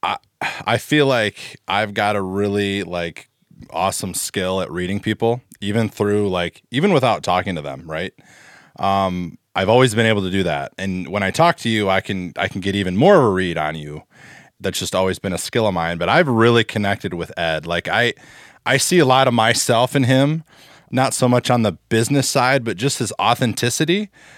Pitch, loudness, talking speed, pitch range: 110 Hz, -18 LUFS, 205 wpm, 95-125 Hz